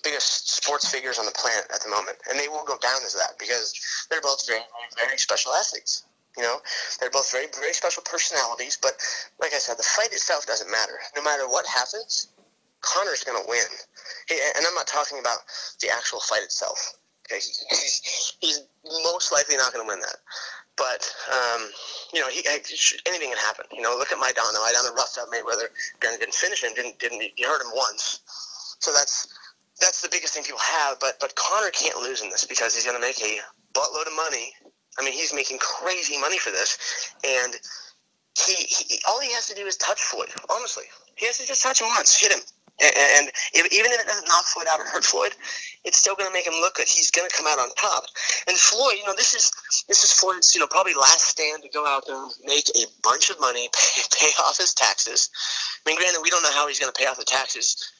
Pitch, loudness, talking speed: 195 Hz, -21 LUFS, 230 wpm